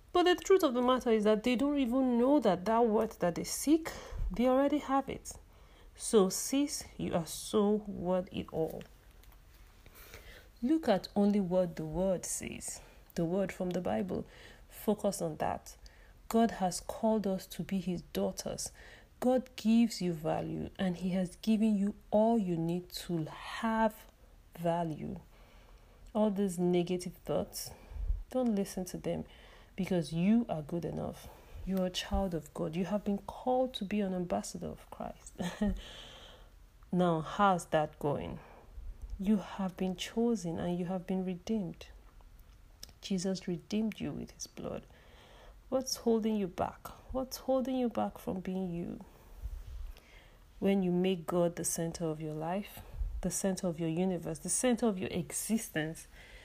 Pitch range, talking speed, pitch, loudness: 170-220 Hz, 155 wpm, 190 Hz, -33 LUFS